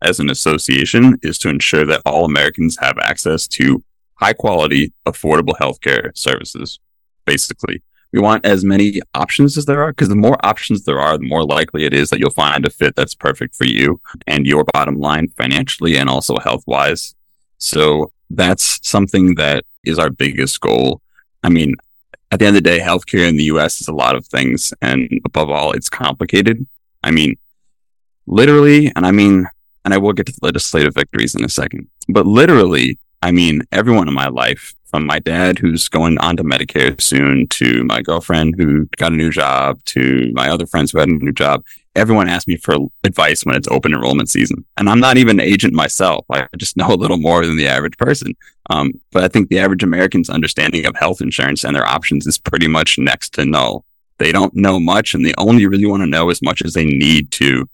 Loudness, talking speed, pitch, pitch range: -13 LUFS, 210 wpm, 85 Hz, 75-100 Hz